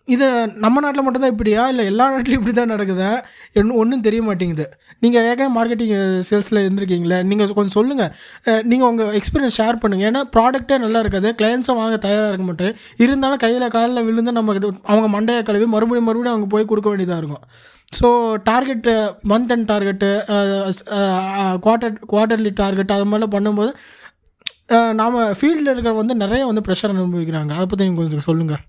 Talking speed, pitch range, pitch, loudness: 155 wpm, 200-235 Hz, 220 Hz, -17 LUFS